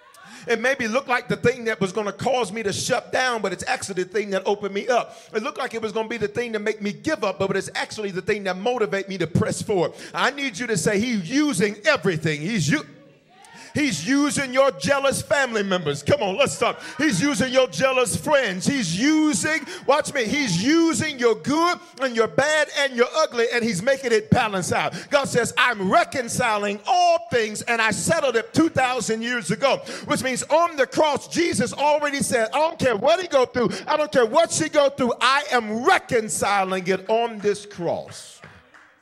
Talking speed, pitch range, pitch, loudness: 210 wpm, 205-280 Hz, 240 Hz, -22 LUFS